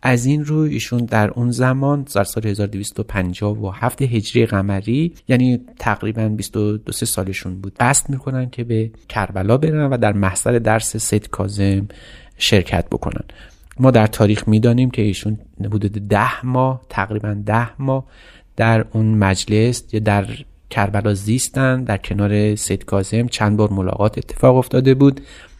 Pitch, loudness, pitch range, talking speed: 110 Hz, -18 LUFS, 100-125 Hz, 145 wpm